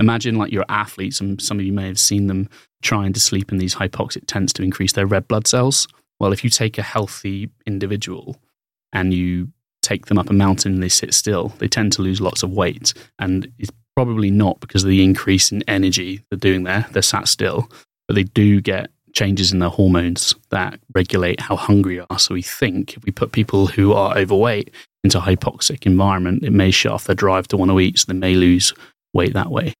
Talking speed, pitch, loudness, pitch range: 225 wpm, 100 Hz, -17 LUFS, 95-110 Hz